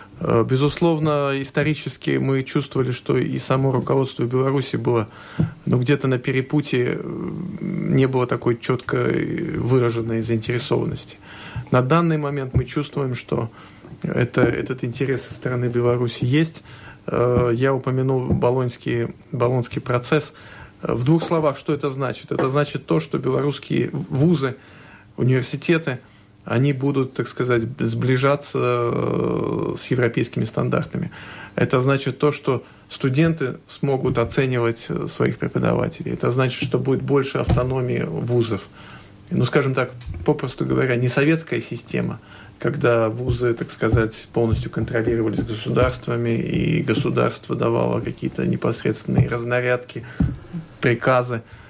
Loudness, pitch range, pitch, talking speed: -22 LUFS, 120-145 Hz, 130 Hz, 115 wpm